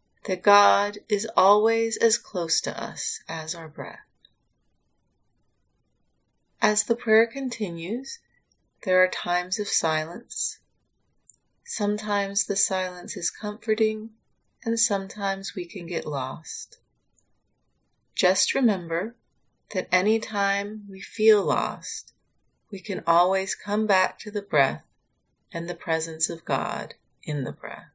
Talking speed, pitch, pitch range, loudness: 120 wpm, 200 Hz, 175-220 Hz, -25 LUFS